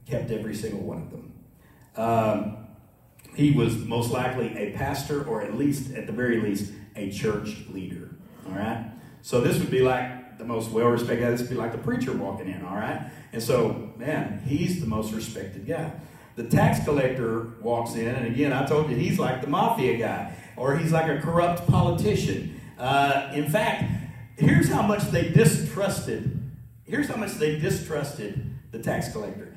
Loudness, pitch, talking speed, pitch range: -26 LUFS, 130 Hz, 180 wpm, 115-150 Hz